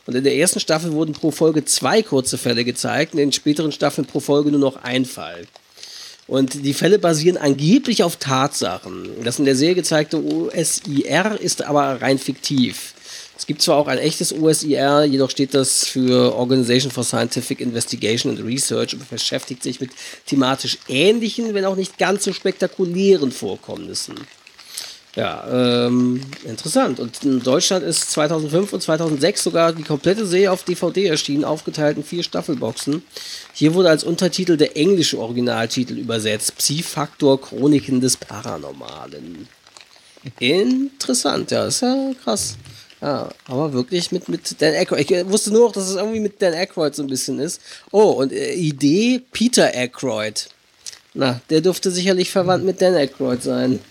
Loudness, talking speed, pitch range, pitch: -18 LUFS, 160 wpm, 130-180 Hz, 150 Hz